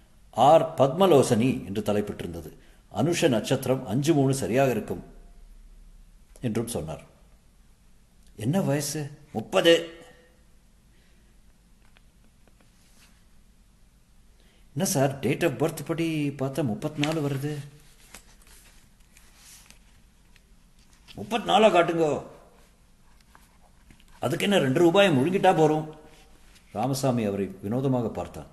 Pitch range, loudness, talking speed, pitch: 110-160 Hz, -24 LUFS, 80 wpm, 140 Hz